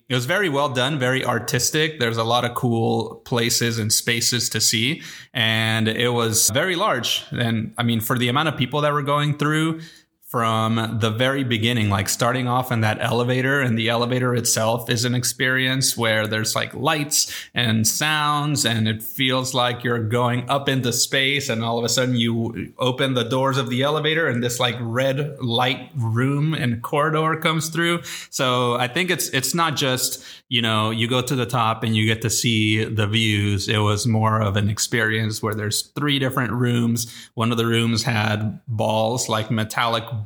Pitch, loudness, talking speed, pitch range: 120 Hz, -20 LUFS, 190 wpm, 115-135 Hz